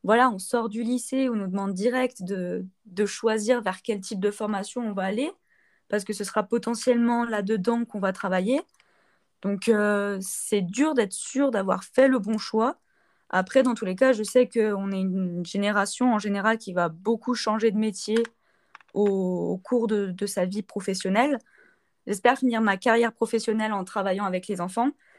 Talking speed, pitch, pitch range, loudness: 185 wpm, 215 Hz, 200-240 Hz, -25 LUFS